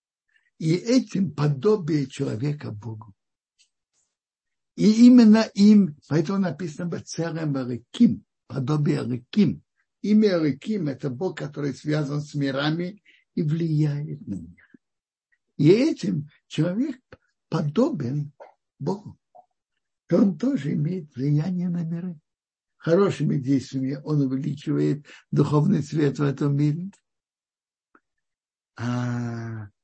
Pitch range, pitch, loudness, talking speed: 140-195 Hz, 155 Hz, -23 LUFS, 90 wpm